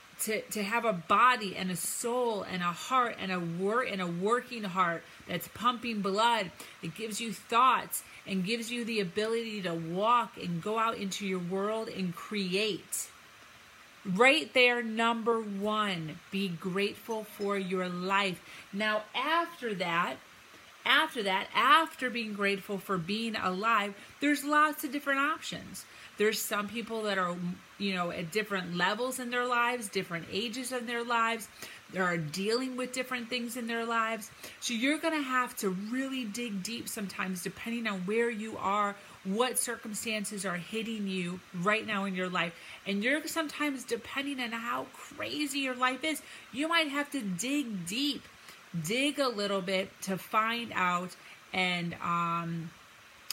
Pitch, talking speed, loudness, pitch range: 215 Hz, 160 wpm, -31 LUFS, 190-240 Hz